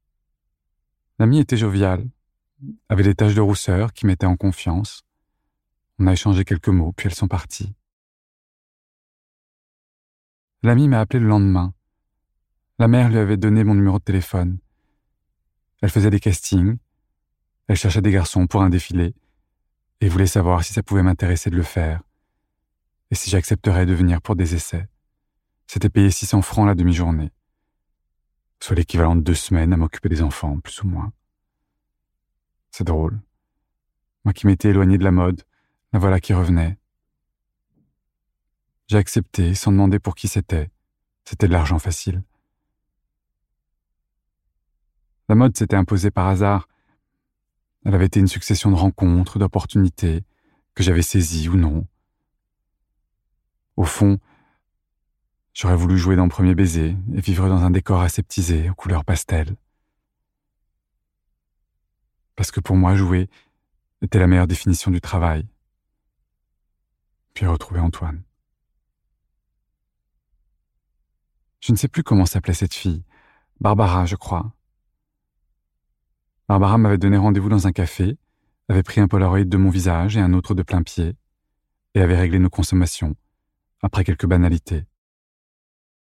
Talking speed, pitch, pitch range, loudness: 135 wpm, 95 Hz, 85-100 Hz, -19 LUFS